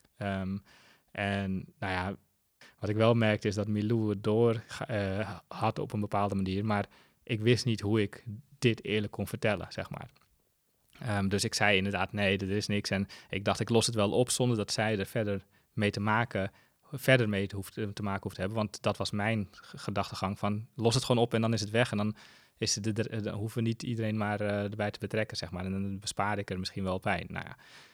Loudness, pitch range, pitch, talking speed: -31 LUFS, 100-110 Hz, 105 Hz, 225 wpm